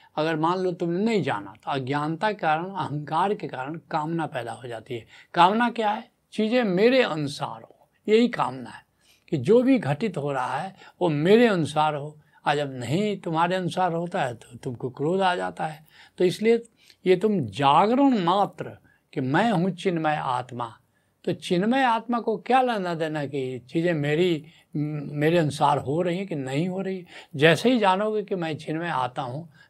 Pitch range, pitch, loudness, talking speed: 145-195 Hz, 165 Hz, -24 LUFS, 185 wpm